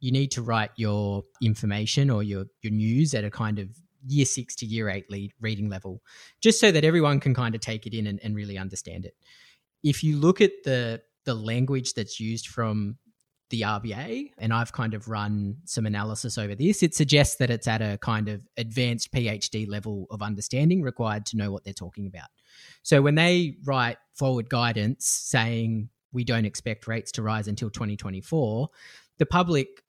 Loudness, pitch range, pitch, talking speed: -26 LUFS, 105-135 Hz, 115 Hz, 190 wpm